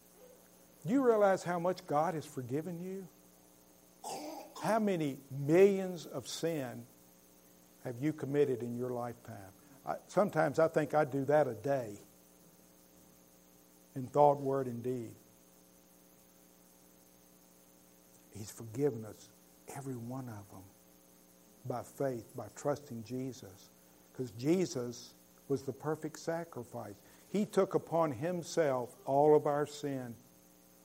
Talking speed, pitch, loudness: 115 wpm, 120 Hz, -34 LUFS